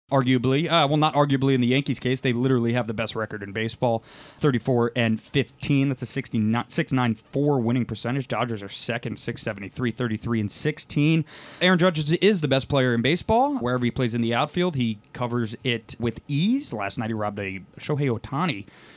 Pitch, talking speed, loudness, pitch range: 125 Hz, 185 wpm, -24 LUFS, 115-145 Hz